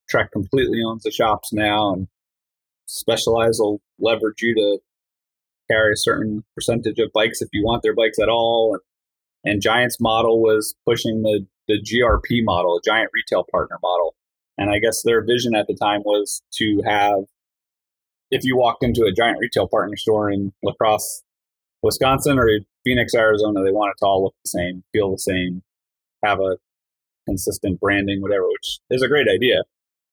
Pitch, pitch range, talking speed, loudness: 105 Hz, 100-115 Hz, 175 wpm, -19 LUFS